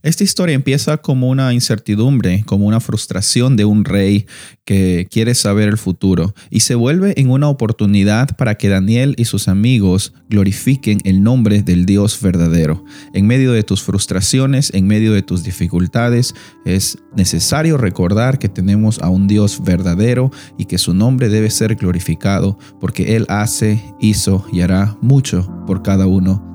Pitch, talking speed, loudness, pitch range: 105 Hz, 160 wpm, -14 LUFS, 95-125 Hz